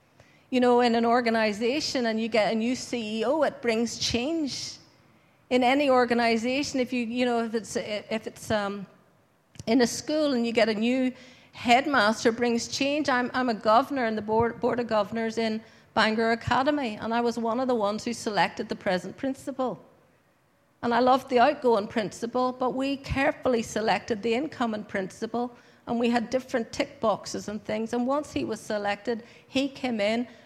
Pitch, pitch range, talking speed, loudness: 235 Hz, 220-255 Hz, 180 wpm, -26 LUFS